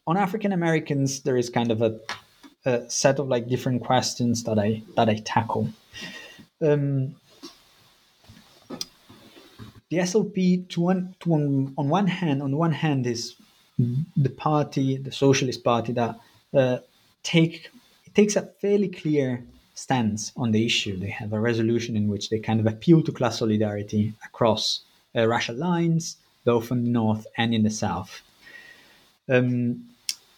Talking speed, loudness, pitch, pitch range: 150 wpm, -24 LUFS, 125 Hz, 115-160 Hz